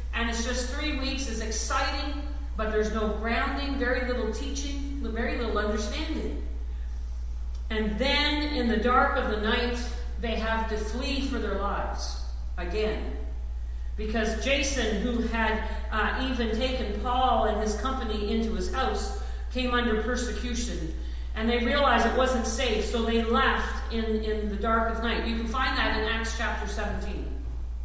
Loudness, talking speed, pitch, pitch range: -28 LUFS, 155 wpm, 225 Hz, 210-250 Hz